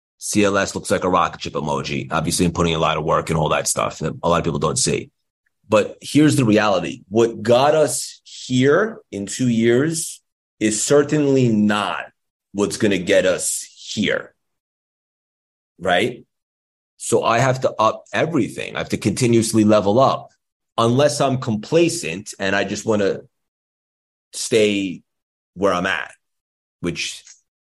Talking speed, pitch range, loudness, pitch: 155 wpm, 95-125 Hz, -19 LUFS, 105 Hz